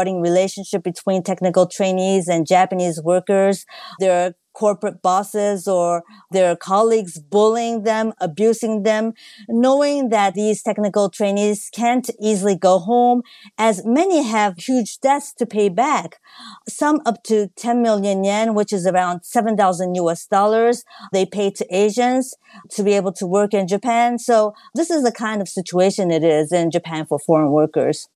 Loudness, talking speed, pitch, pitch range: -18 LUFS, 150 wpm, 205 Hz, 185-225 Hz